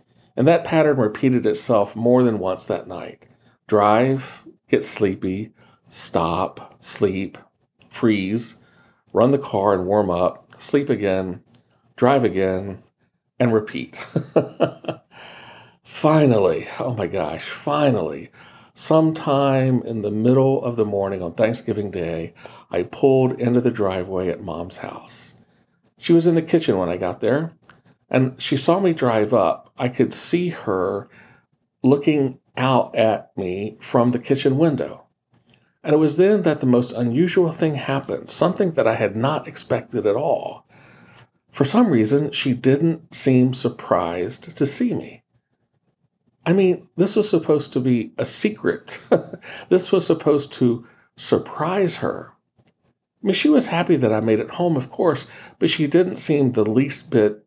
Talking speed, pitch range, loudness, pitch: 145 wpm, 110-155 Hz, -20 LUFS, 130 Hz